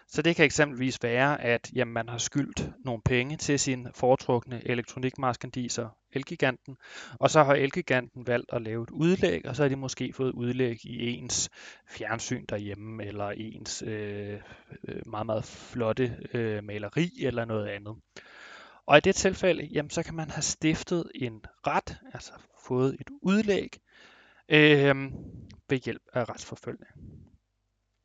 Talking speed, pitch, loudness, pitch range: 150 wpm, 125 Hz, -28 LUFS, 115-145 Hz